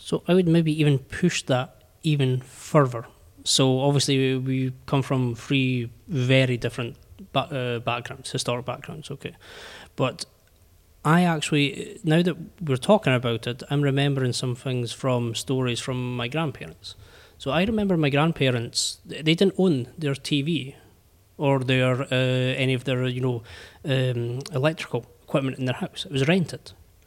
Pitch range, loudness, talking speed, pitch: 120-145 Hz, -24 LUFS, 145 wpm, 130 Hz